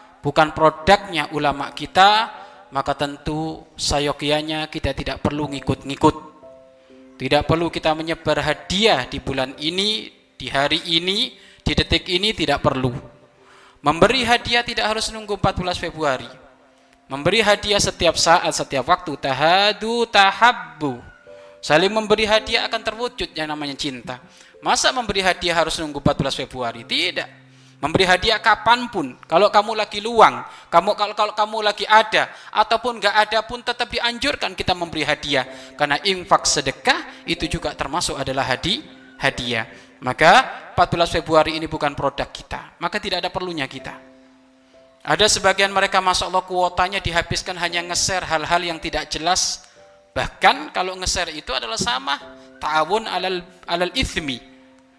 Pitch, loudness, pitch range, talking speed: 165 Hz, -19 LUFS, 140-200 Hz, 135 wpm